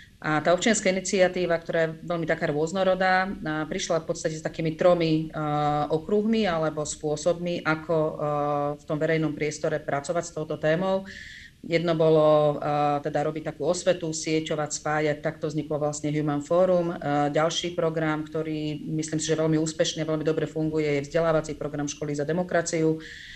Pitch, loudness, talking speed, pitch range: 155 Hz, -26 LUFS, 145 wpm, 150-170 Hz